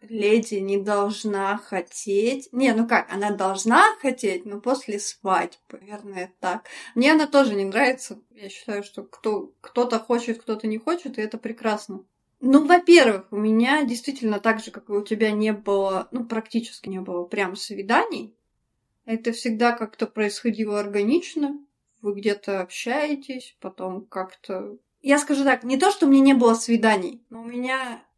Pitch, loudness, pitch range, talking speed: 225 Hz, -22 LUFS, 205-255 Hz, 160 wpm